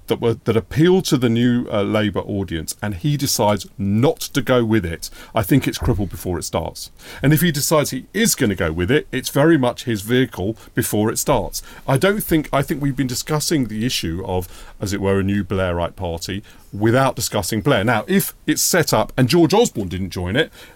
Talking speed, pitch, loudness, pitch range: 220 wpm, 115 Hz, -19 LUFS, 100-145 Hz